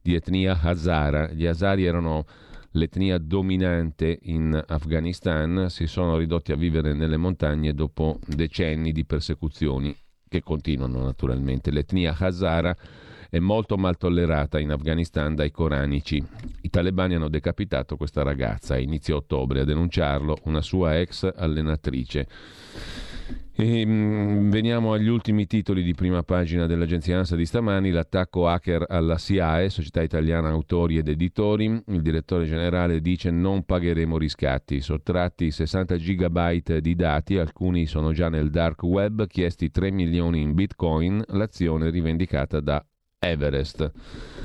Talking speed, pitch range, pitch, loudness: 130 wpm, 80-90 Hz, 85 Hz, -24 LUFS